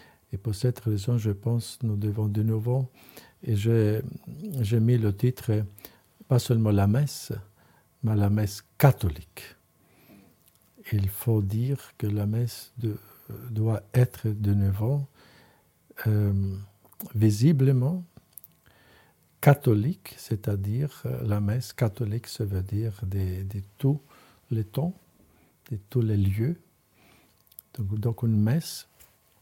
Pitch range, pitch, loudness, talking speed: 105-125 Hz, 110 Hz, -27 LUFS, 115 wpm